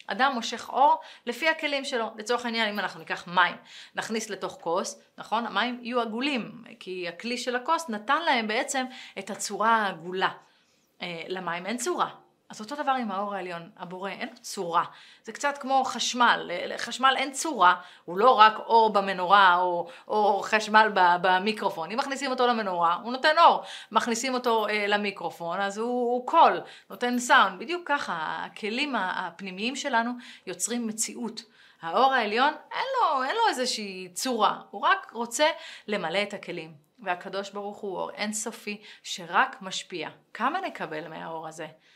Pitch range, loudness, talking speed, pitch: 190-255 Hz, -26 LUFS, 155 wpm, 225 Hz